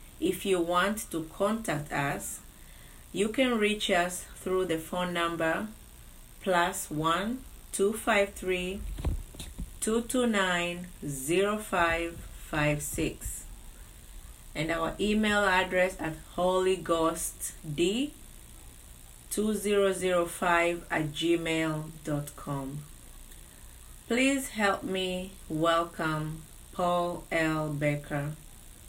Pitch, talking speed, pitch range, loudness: 175 Hz, 60 wpm, 160-195 Hz, -30 LUFS